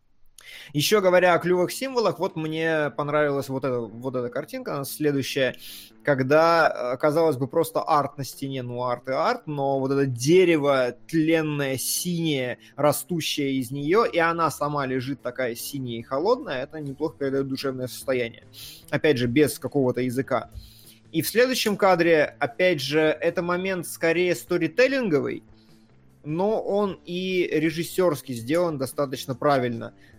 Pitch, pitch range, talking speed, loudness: 145 Hz, 130-165 Hz, 140 wpm, -24 LUFS